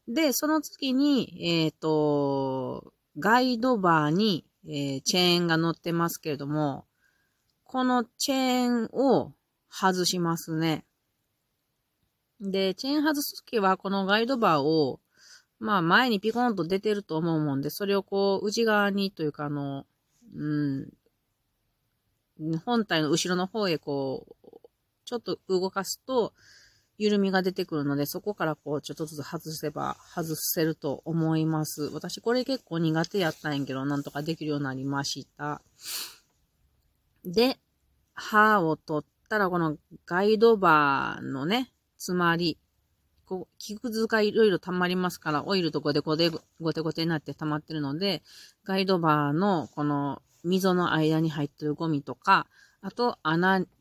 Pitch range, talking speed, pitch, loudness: 150-205 Hz, 280 characters per minute, 165 Hz, -27 LUFS